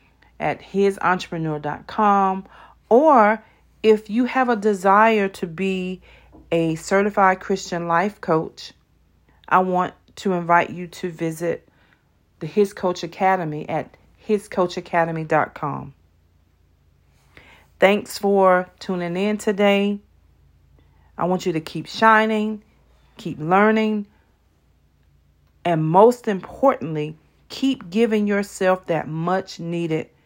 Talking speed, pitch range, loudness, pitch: 100 wpm, 150-200 Hz, -20 LUFS, 180 Hz